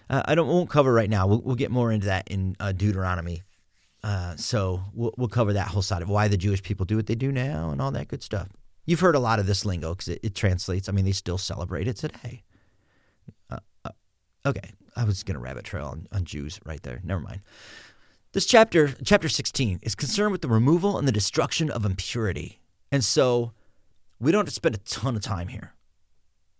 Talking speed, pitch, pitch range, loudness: 225 wpm, 105 Hz, 95-125 Hz, -25 LUFS